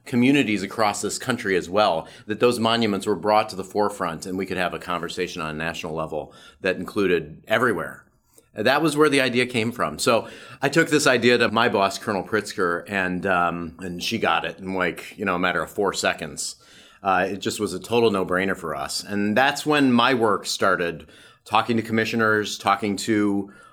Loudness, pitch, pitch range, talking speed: -22 LUFS, 105 Hz, 95-115 Hz, 200 wpm